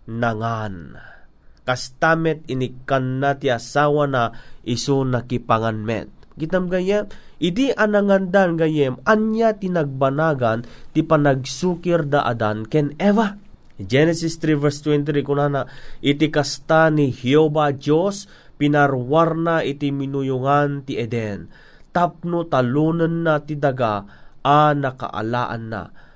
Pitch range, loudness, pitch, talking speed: 125-160 Hz, -20 LUFS, 145 Hz, 110 wpm